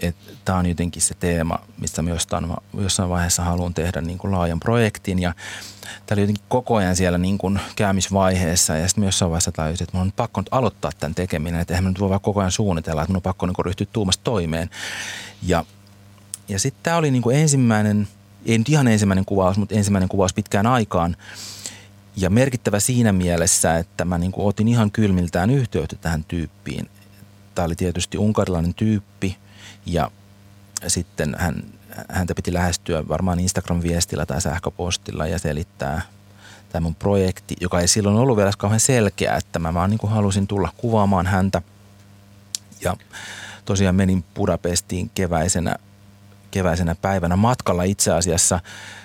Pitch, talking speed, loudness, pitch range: 95 Hz, 155 wpm, -21 LUFS, 90-100 Hz